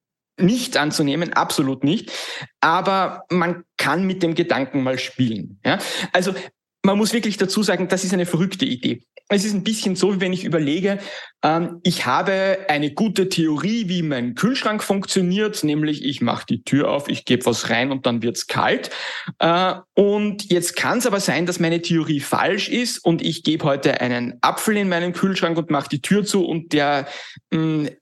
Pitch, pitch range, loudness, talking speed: 175 Hz, 150-195 Hz, -20 LUFS, 185 wpm